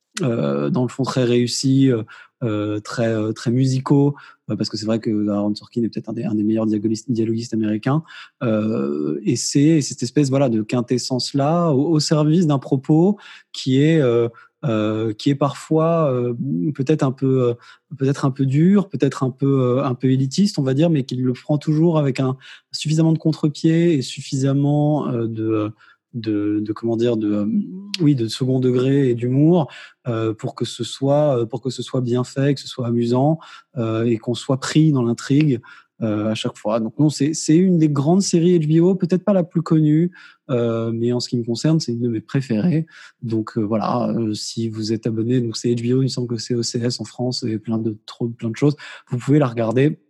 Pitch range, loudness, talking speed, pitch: 115-150 Hz, -20 LUFS, 210 wpm, 130 Hz